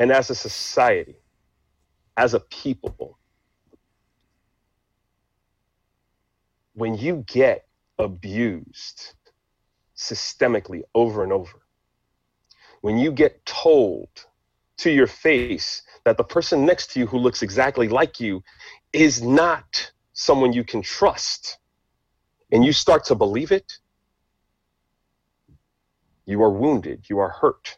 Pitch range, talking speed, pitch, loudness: 100-135 Hz, 110 wpm, 115 Hz, -21 LUFS